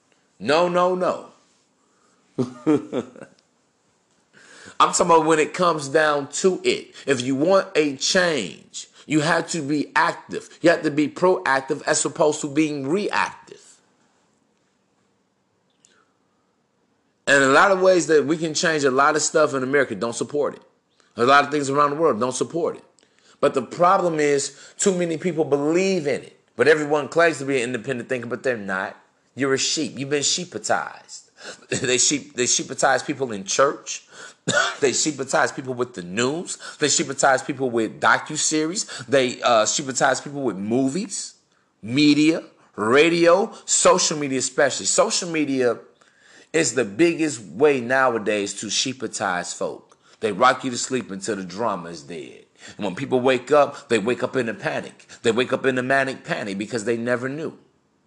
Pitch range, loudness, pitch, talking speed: 130-165 Hz, -21 LUFS, 145 Hz, 160 wpm